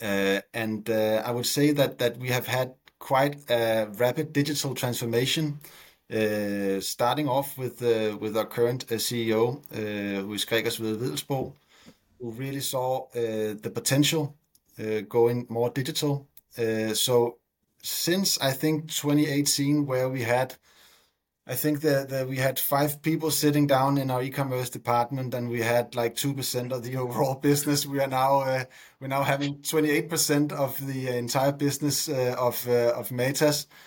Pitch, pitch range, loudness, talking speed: 130 Hz, 120-145 Hz, -26 LUFS, 165 wpm